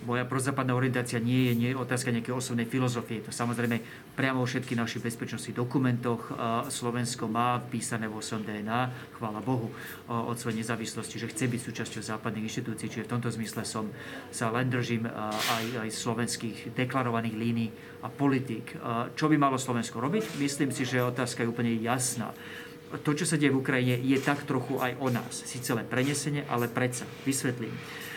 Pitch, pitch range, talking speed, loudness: 120 Hz, 115-130 Hz, 175 wpm, -30 LUFS